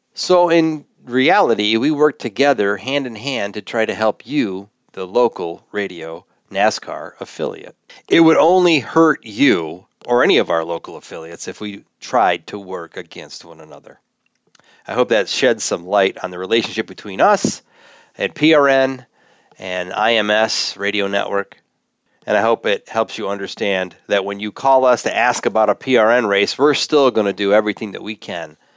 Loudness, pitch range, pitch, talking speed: -17 LUFS, 100-135 Hz, 110 Hz, 170 wpm